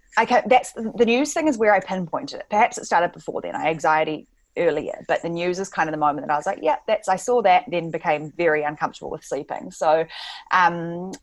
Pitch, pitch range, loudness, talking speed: 180 Hz, 155-215 Hz, -22 LUFS, 230 wpm